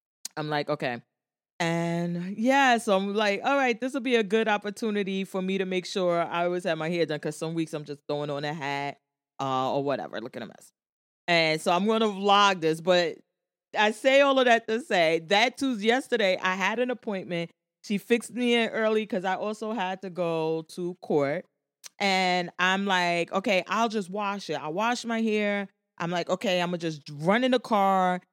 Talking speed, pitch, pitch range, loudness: 210 wpm, 185 Hz, 165-220 Hz, -26 LUFS